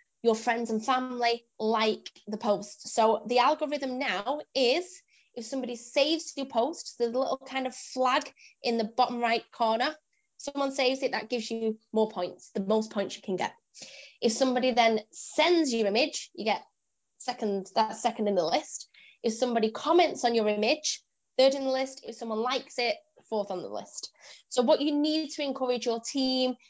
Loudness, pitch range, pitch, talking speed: -29 LUFS, 225-275 Hz, 245 Hz, 185 wpm